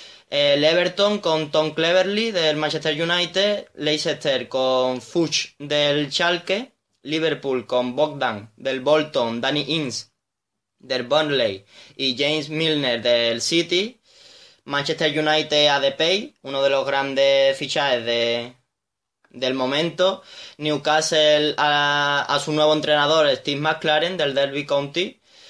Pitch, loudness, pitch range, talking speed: 150 Hz, -20 LUFS, 135-160 Hz, 120 wpm